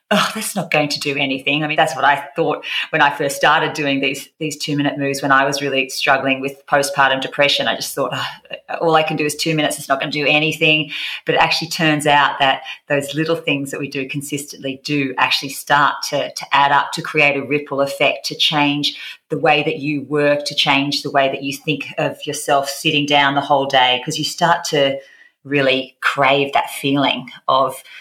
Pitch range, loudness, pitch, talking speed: 140-150 Hz, -17 LUFS, 145 Hz, 220 wpm